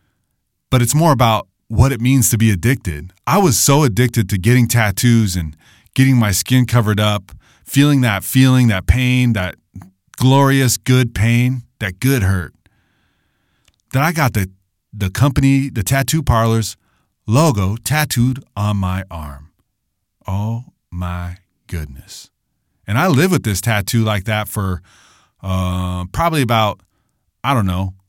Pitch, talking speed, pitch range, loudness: 110 Hz, 145 wpm, 95-130 Hz, -16 LUFS